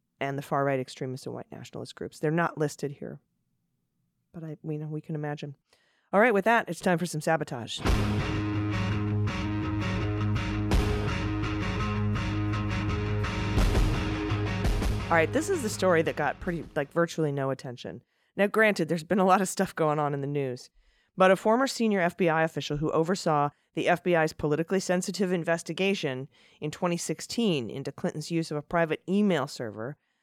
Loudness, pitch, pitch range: -28 LUFS, 150 Hz, 105-170 Hz